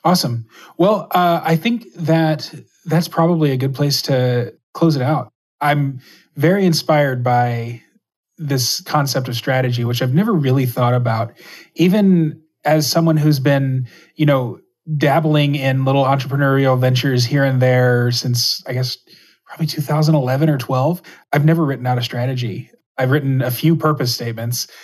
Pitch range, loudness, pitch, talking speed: 125-155 Hz, -17 LUFS, 140 Hz, 150 wpm